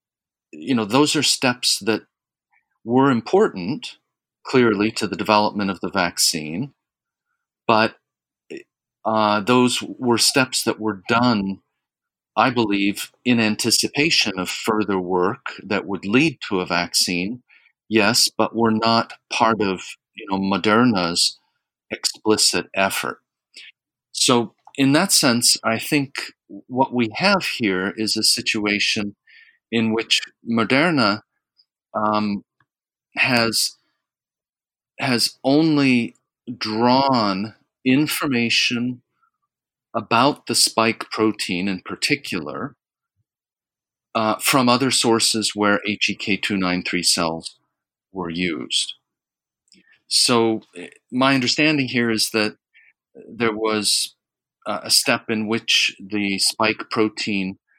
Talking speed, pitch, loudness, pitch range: 105 wpm, 110 Hz, -19 LUFS, 100-125 Hz